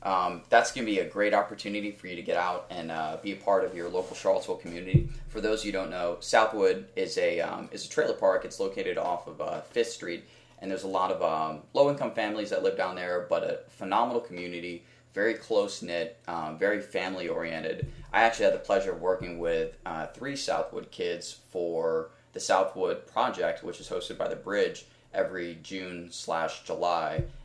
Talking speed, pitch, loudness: 195 wpm, 125 Hz, -30 LUFS